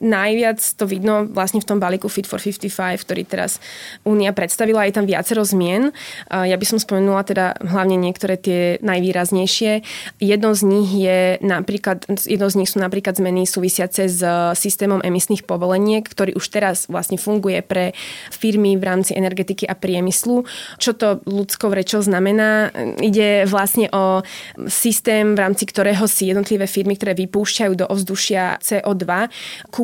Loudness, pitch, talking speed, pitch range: -18 LUFS, 195 Hz, 150 wpm, 185-210 Hz